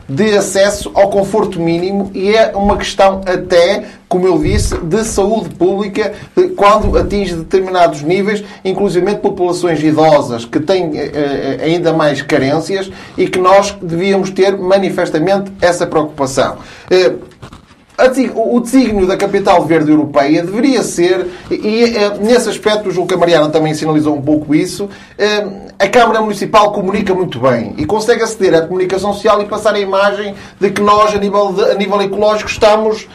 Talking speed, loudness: 150 wpm, -12 LUFS